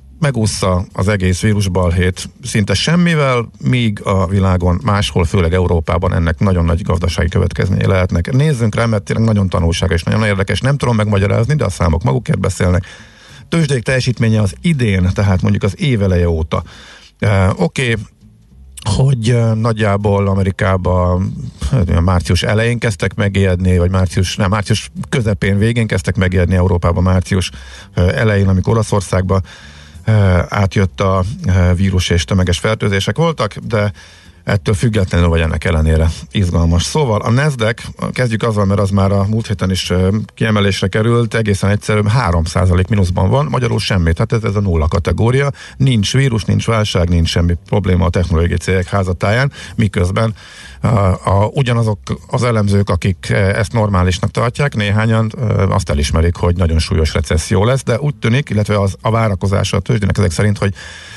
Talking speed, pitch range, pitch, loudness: 145 wpm, 90-110 Hz, 100 Hz, -15 LUFS